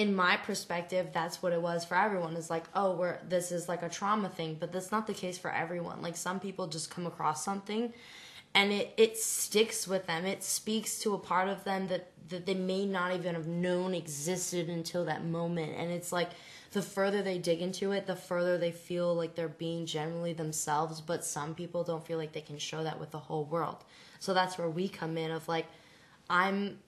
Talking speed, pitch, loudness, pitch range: 220 wpm, 175 Hz, -33 LUFS, 165-190 Hz